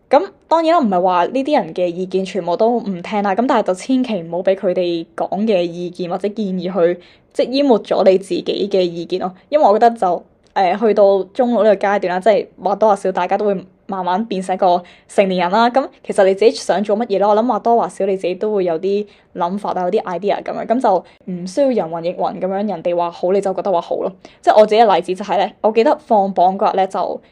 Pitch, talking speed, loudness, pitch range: 195 Hz, 370 characters per minute, -16 LUFS, 180-220 Hz